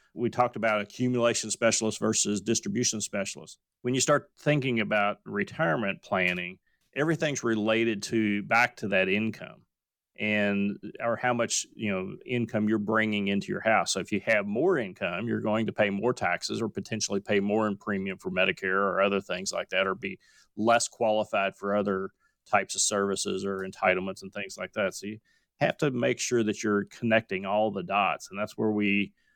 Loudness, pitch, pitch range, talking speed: -28 LUFS, 105 Hz, 100-115 Hz, 185 wpm